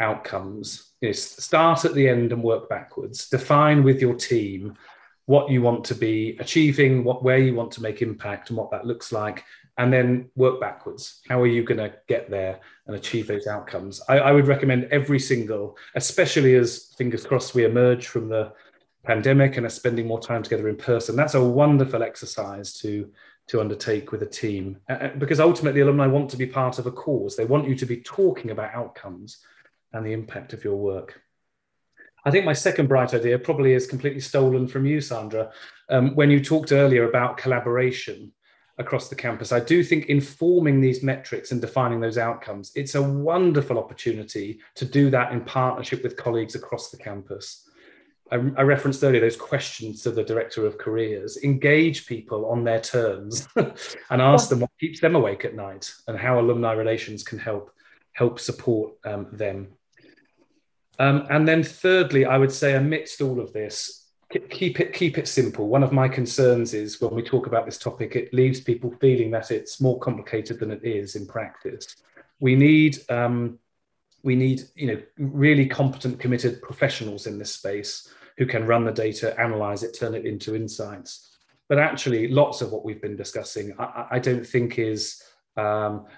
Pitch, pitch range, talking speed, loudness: 125 Hz, 115-140 Hz, 185 wpm, -23 LUFS